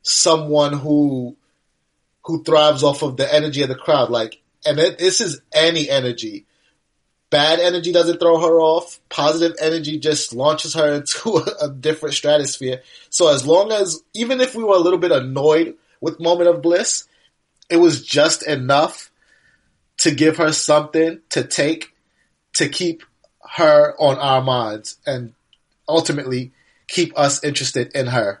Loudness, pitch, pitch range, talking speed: -17 LUFS, 155 Hz, 145-170 Hz, 155 wpm